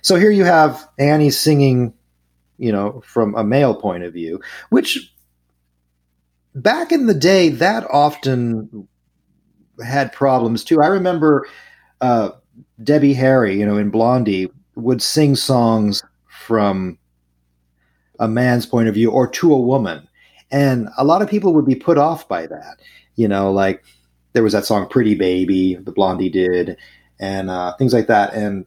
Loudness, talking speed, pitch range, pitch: -16 LUFS, 155 wpm, 95-135 Hz, 110 Hz